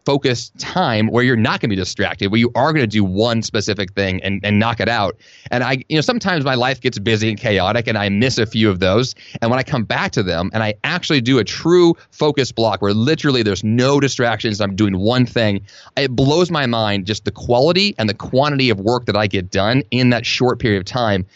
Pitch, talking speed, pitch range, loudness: 115 Hz, 240 wpm, 105-135 Hz, -17 LUFS